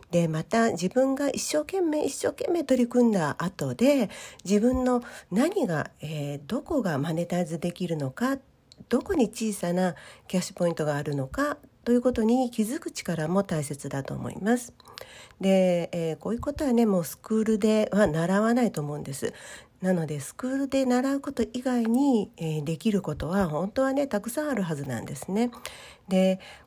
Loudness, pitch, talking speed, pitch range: -27 LUFS, 210 Hz, 335 characters per minute, 170-250 Hz